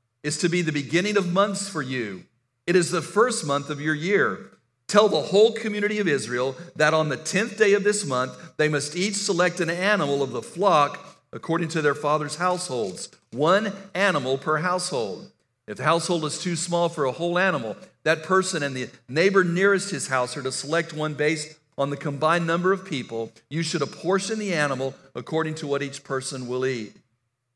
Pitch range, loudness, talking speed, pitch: 140-185 Hz, -24 LUFS, 195 wpm, 155 Hz